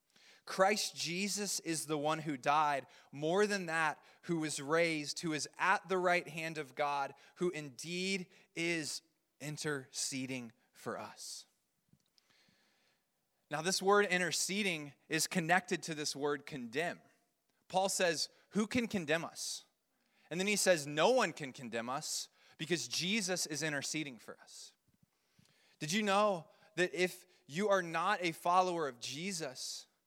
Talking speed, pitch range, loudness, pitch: 140 wpm, 150-190 Hz, -35 LUFS, 170 Hz